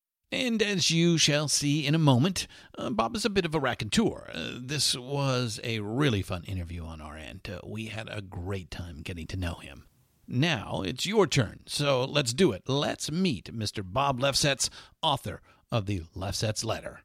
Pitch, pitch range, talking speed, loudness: 120 Hz, 95-145 Hz, 190 wpm, -28 LUFS